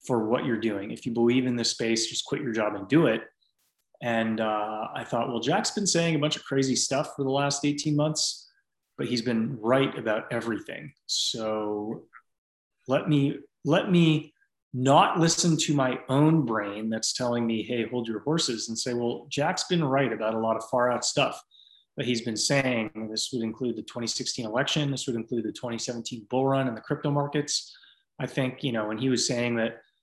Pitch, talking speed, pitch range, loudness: 125 Hz, 205 wpm, 115-145 Hz, -27 LUFS